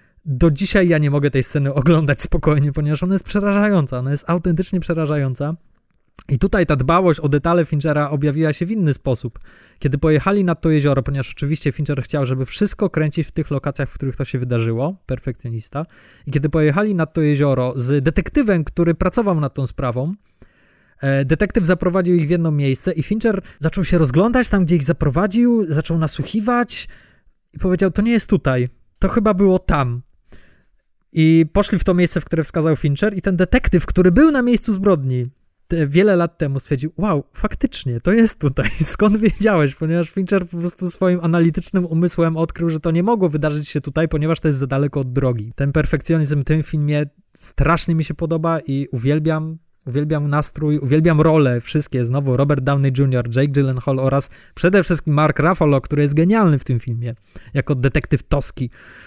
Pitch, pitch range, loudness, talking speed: 155 Hz, 140-180 Hz, -18 LUFS, 180 wpm